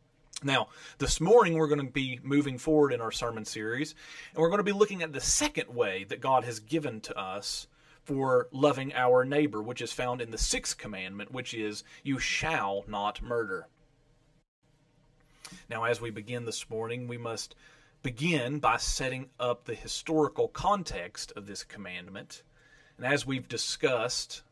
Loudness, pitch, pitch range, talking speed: -30 LUFS, 145 Hz, 120-155 Hz, 165 wpm